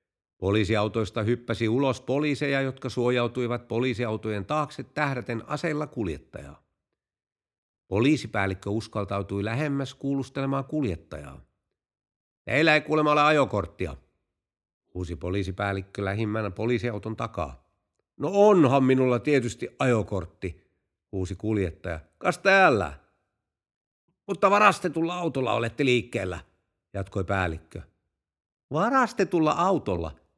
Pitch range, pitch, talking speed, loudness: 95-140 Hz, 115 Hz, 85 wpm, -26 LUFS